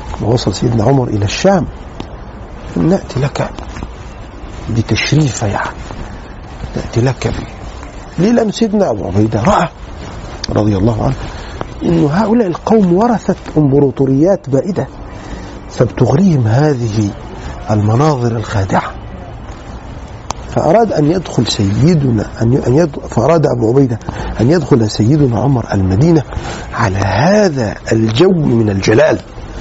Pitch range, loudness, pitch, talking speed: 110-155 Hz, -13 LUFS, 120 Hz, 105 wpm